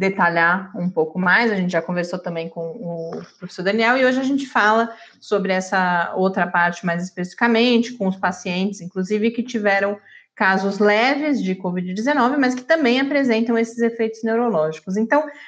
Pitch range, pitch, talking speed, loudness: 180-235 Hz, 200 Hz, 165 wpm, -19 LUFS